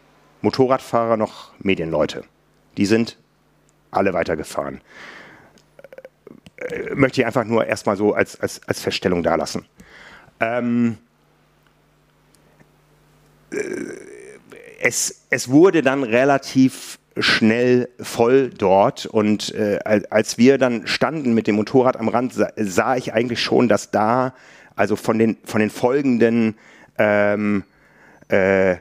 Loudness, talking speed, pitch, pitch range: -19 LUFS, 110 wpm, 120 Hz, 110-135 Hz